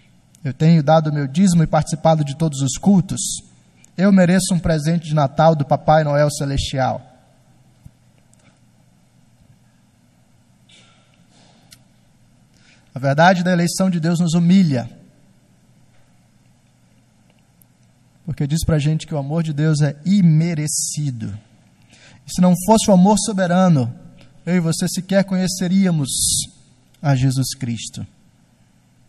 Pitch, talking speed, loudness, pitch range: 155 Hz, 120 wpm, -17 LUFS, 130-175 Hz